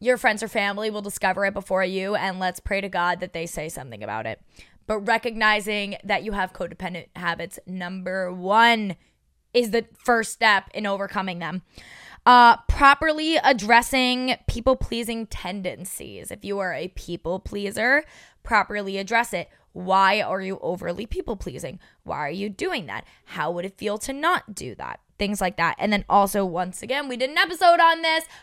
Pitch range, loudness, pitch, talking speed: 185-235 Hz, -23 LUFS, 200 Hz, 175 wpm